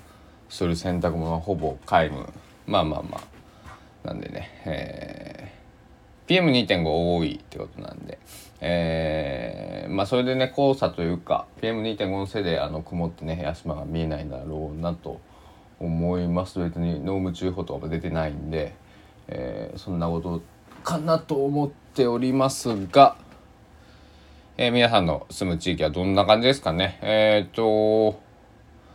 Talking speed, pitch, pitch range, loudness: 270 characters per minute, 90 Hz, 80-110 Hz, -24 LUFS